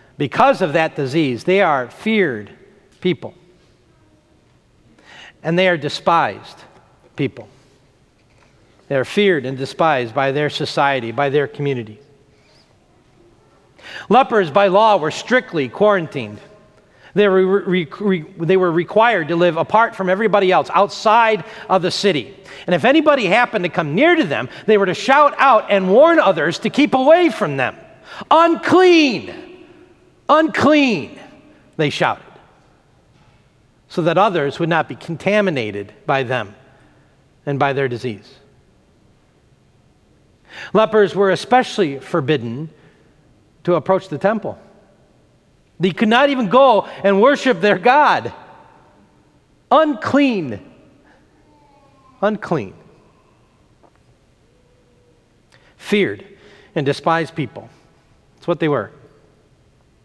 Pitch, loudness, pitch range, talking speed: 180 Hz, -16 LUFS, 140-215 Hz, 115 wpm